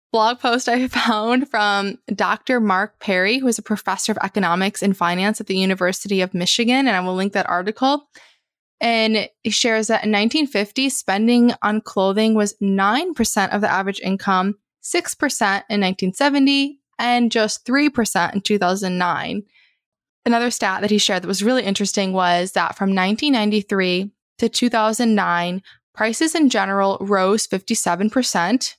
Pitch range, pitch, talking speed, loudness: 195-240 Hz, 210 Hz, 145 wpm, -19 LUFS